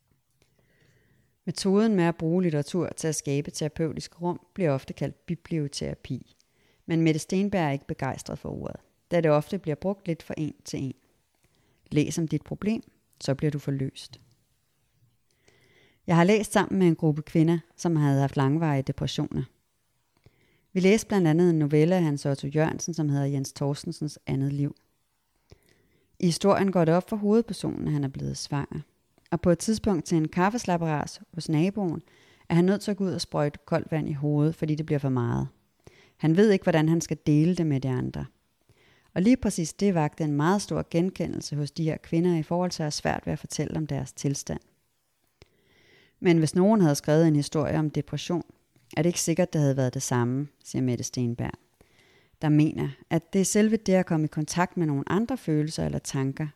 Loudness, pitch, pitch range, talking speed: -26 LUFS, 155 Hz, 140-175 Hz, 195 wpm